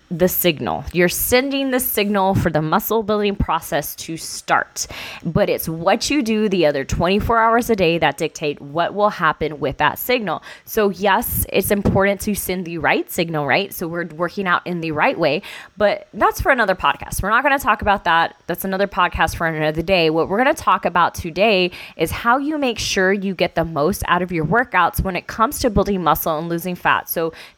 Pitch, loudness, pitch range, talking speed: 185 Hz, -18 LUFS, 165-210 Hz, 215 wpm